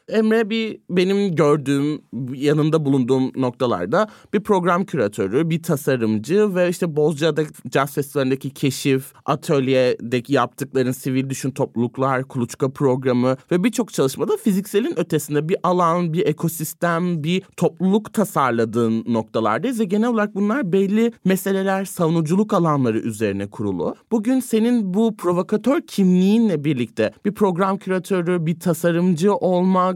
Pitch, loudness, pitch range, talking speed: 165 Hz, -20 LUFS, 135-195 Hz, 120 wpm